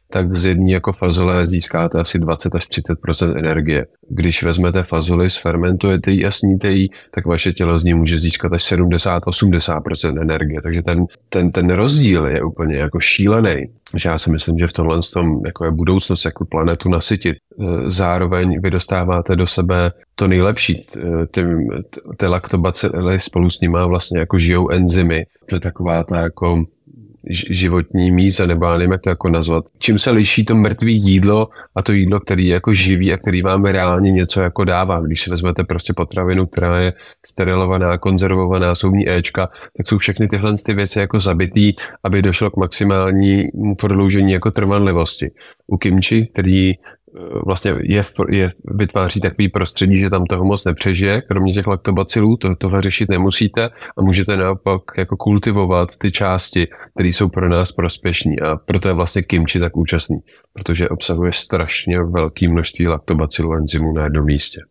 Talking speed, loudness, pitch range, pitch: 165 wpm, -16 LUFS, 85-95 Hz, 90 Hz